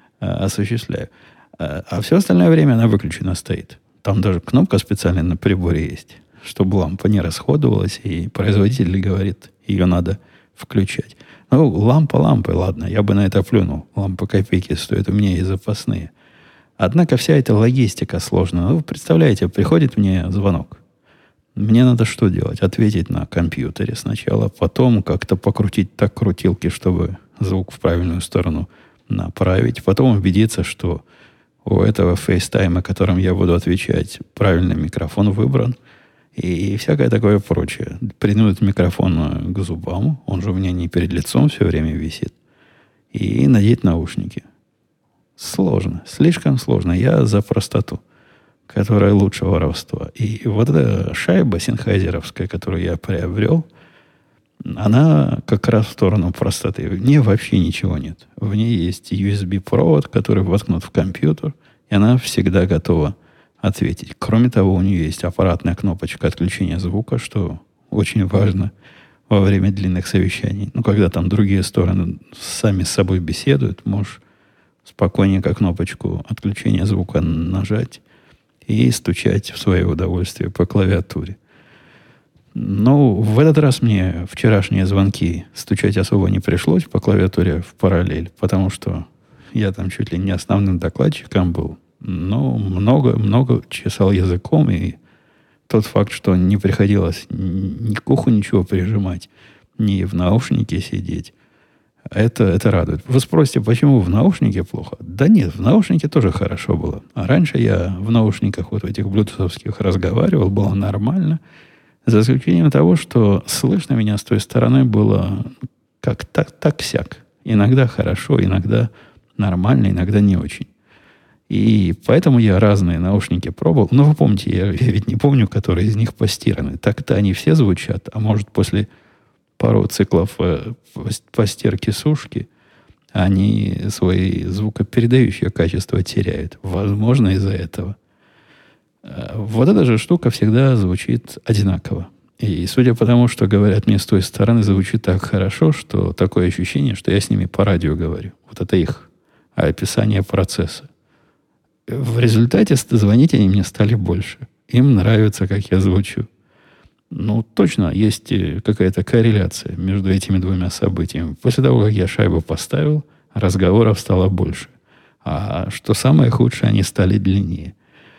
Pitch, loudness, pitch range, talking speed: 100 Hz, -17 LUFS, 95-115 Hz, 140 wpm